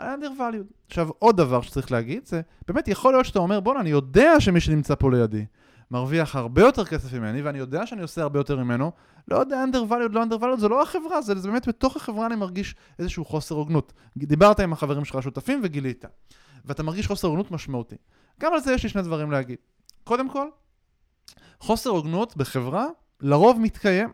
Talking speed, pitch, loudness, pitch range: 190 wpm, 170 Hz, -23 LUFS, 140-230 Hz